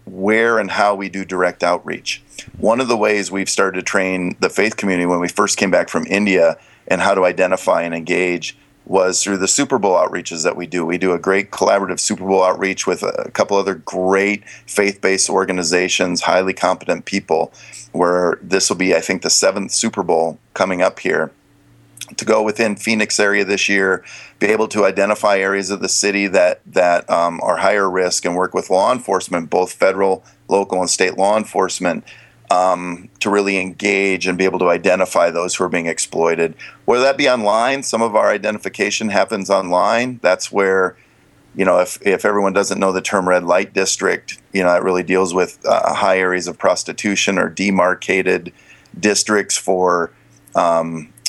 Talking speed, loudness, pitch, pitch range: 185 wpm, -16 LUFS, 95 Hz, 90-100 Hz